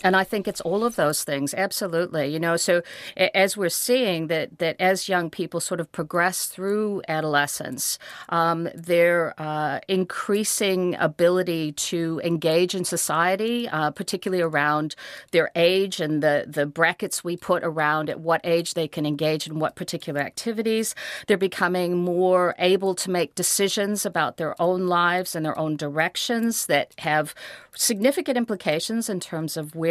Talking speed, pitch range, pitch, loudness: 160 wpm, 160-195 Hz, 175 Hz, -23 LUFS